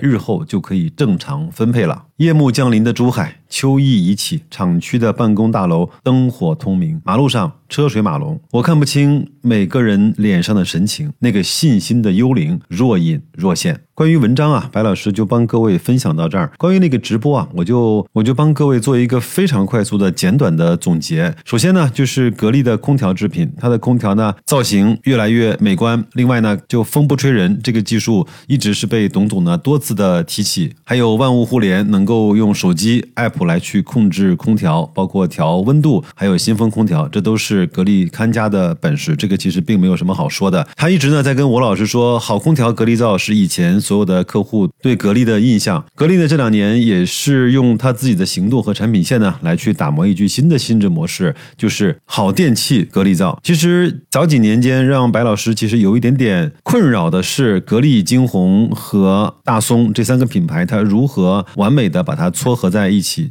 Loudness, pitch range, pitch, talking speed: -14 LUFS, 110-160 Hz, 125 Hz, 305 characters per minute